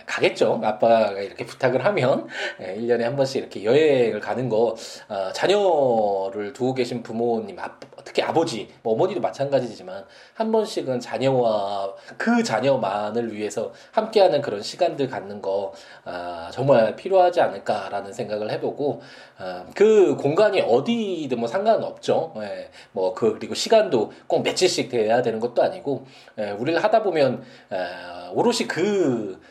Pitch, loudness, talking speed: 135 Hz, -22 LUFS, 290 characters per minute